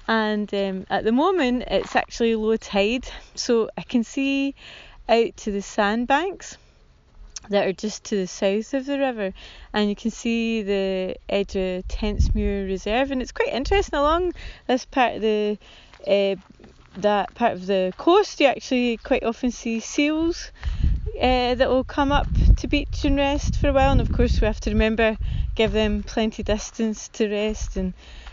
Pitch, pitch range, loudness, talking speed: 225 Hz, 205-260 Hz, -23 LUFS, 170 wpm